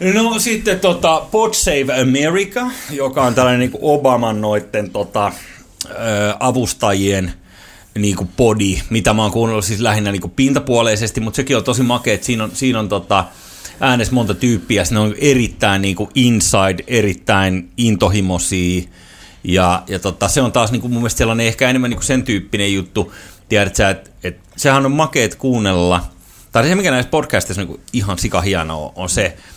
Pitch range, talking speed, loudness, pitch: 95-125 Hz, 175 wpm, -15 LUFS, 110 Hz